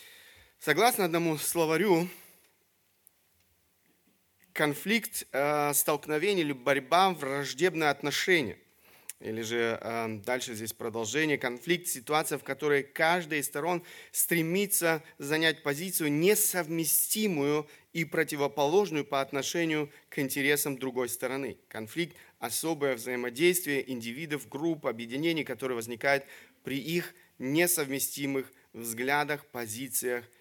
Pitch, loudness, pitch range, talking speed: 145 Hz, -29 LUFS, 130-165 Hz, 90 wpm